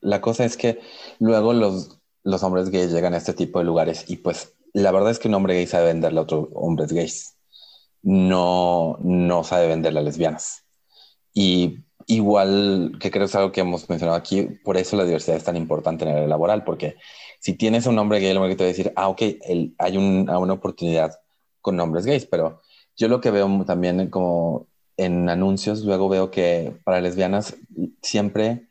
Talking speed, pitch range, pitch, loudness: 205 wpm, 85-100 Hz, 95 Hz, -21 LUFS